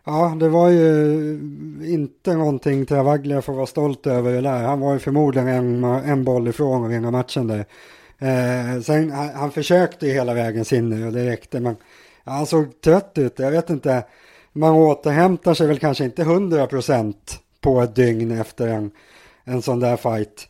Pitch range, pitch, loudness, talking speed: 125-150 Hz, 135 Hz, -19 LUFS, 185 wpm